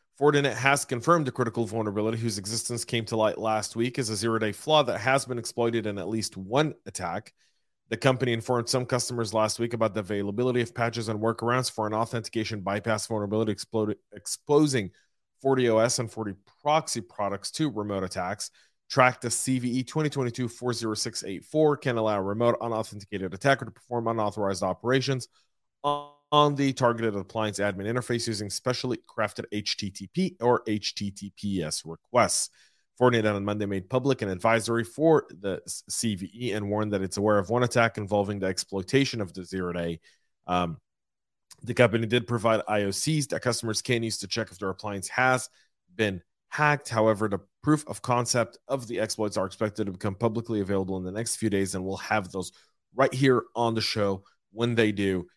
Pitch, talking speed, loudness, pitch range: 115 Hz, 170 wpm, -27 LUFS, 105-125 Hz